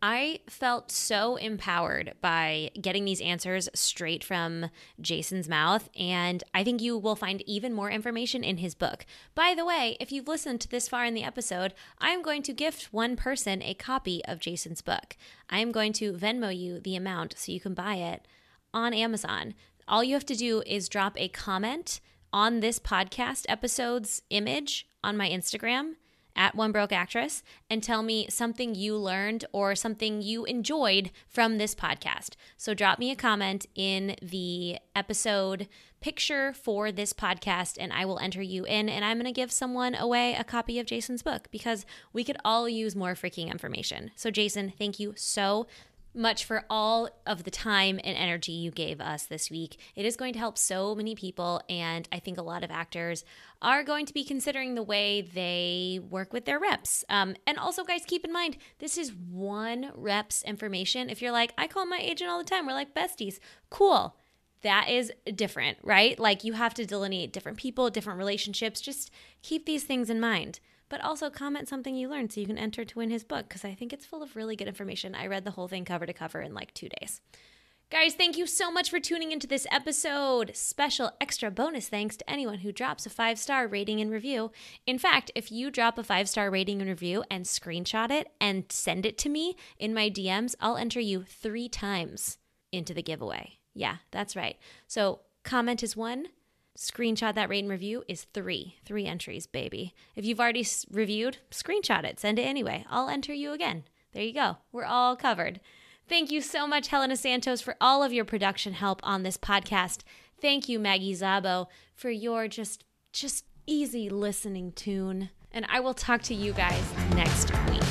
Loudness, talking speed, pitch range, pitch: -30 LUFS, 195 wpm, 195-250 Hz, 220 Hz